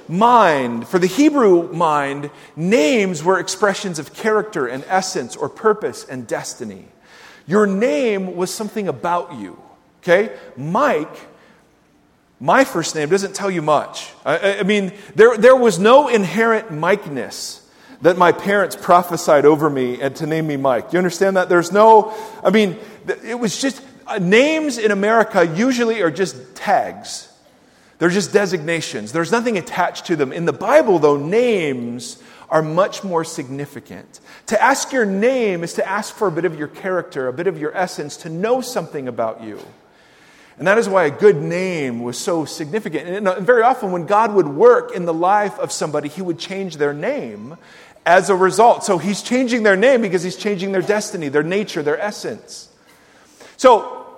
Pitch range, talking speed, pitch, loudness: 165-220 Hz, 170 wpm, 190 Hz, -17 LUFS